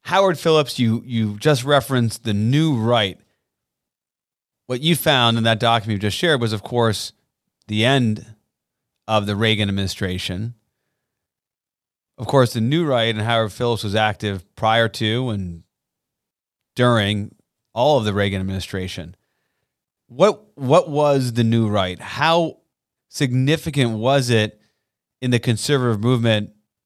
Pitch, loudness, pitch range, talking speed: 115 Hz, -19 LUFS, 105-130 Hz, 135 wpm